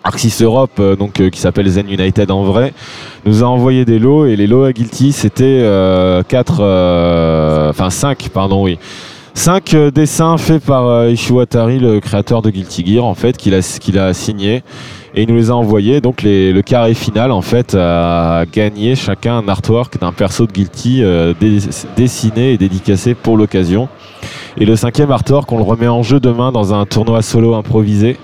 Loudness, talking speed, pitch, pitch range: -11 LUFS, 195 wpm, 110 Hz, 95-125 Hz